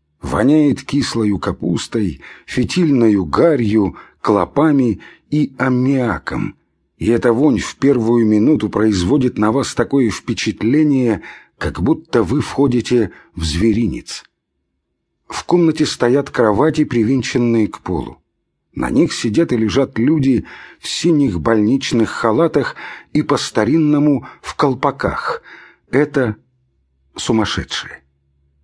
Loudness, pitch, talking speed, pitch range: -16 LUFS, 120 Hz, 100 wpm, 100-140 Hz